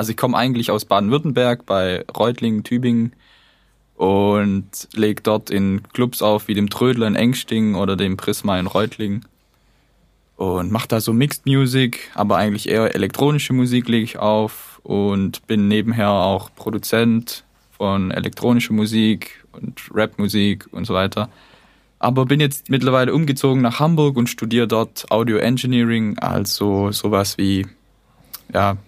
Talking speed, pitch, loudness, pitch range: 140 wpm, 110 Hz, -19 LUFS, 100-120 Hz